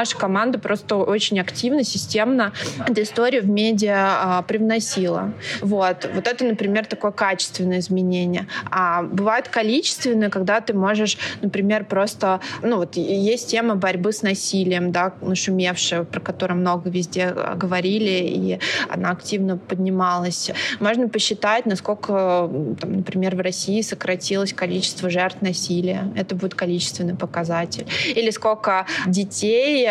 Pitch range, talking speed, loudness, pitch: 180-215 Hz, 130 wpm, -21 LUFS, 195 Hz